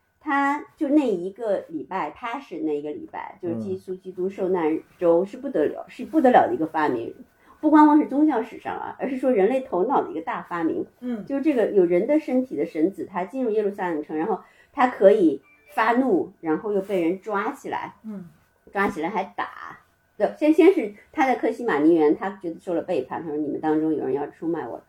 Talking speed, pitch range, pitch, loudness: 315 characters per minute, 185-305 Hz, 245 Hz, -23 LUFS